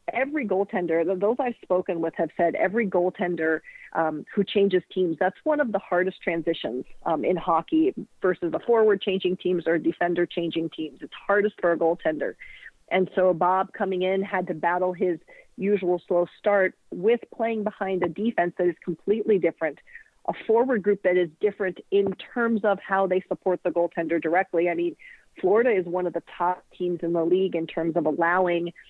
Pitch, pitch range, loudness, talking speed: 185 Hz, 170-205 Hz, -25 LUFS, 185 wpm